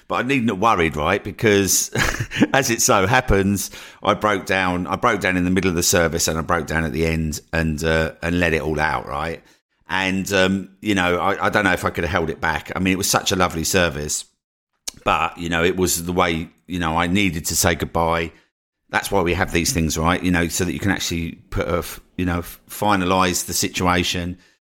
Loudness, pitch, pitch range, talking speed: -20 LUFS, 90 Hz, 85-95 Hz, 235 wpm